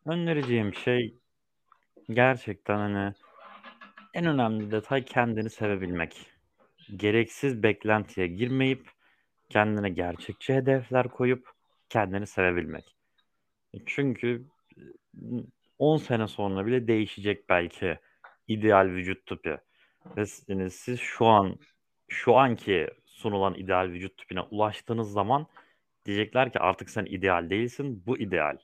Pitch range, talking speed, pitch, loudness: 95-125 Hz, 105 wpm, 110 Hz, -28 LUFS